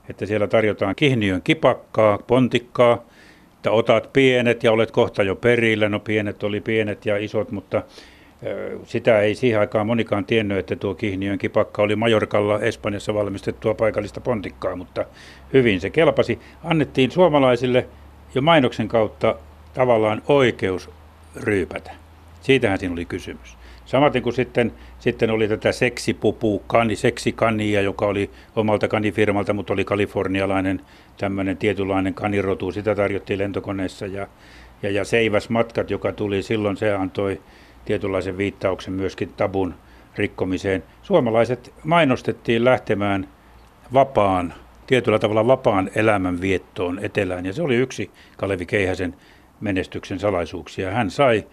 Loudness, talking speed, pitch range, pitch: -21 LUFS, 125 wpm, 95-115 Hz, 105 Hz